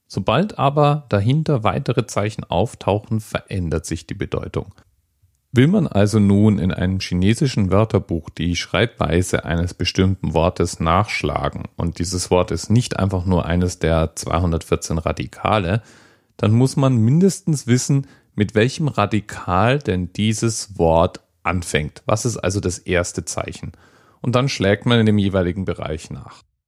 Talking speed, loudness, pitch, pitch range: 140 wpm, -19 LUFS, 100 Hz, 90-115 Hz